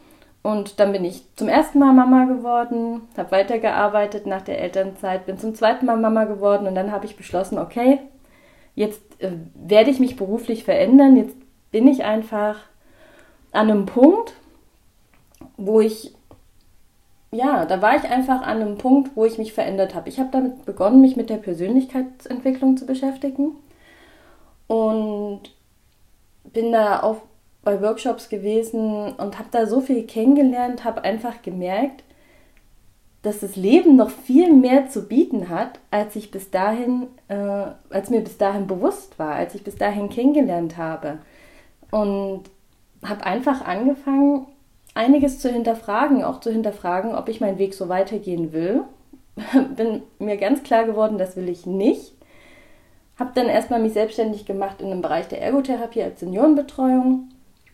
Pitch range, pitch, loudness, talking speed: 200-265 Hz, 225 Hz, -20 LUFS, 150 wpm